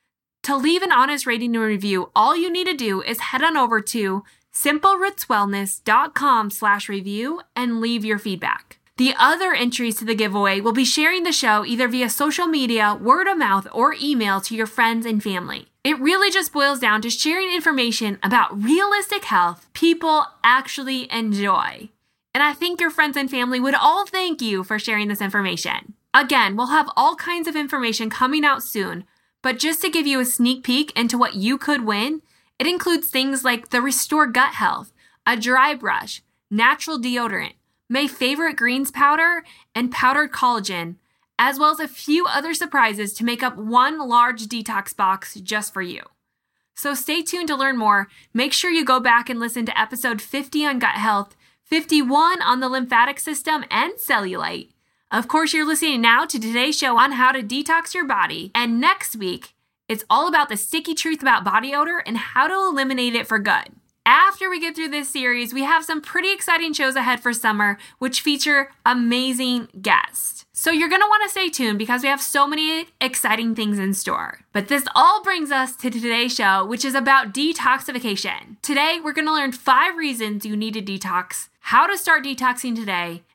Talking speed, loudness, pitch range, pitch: 185 wpm, -19 LUFS, 225-310 Hz, 255 Hz